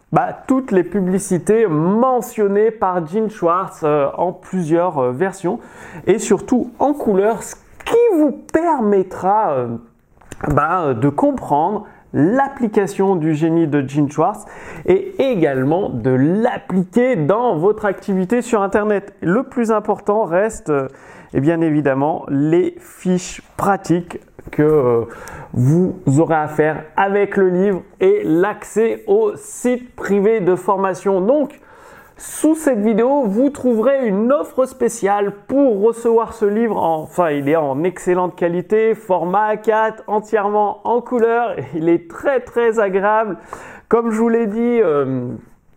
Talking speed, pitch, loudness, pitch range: 135 wpm, 200 Hz, -17 LUFS, 170-235 Hz